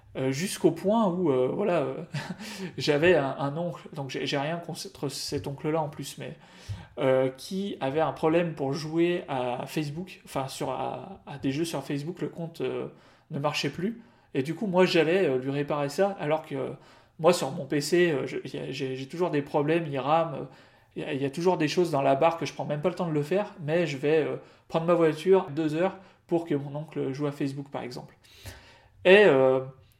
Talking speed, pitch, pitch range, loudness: 220 wpm, 150 Hz, 135-175 Hz, -27 LUFS